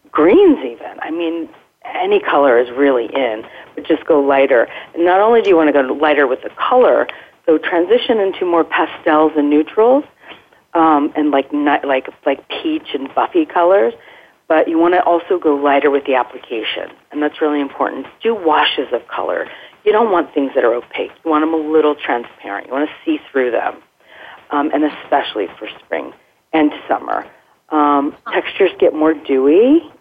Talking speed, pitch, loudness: 180 wpm, 160 Hz, -15 LUFS